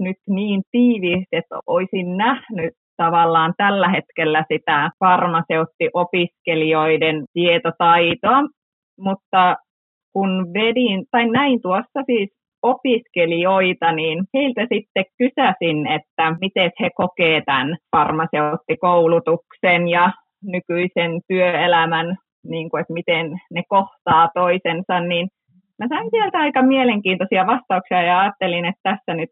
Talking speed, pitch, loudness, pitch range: 105 wpm, 180 Hz, -18 LUFS, 165-200 Hz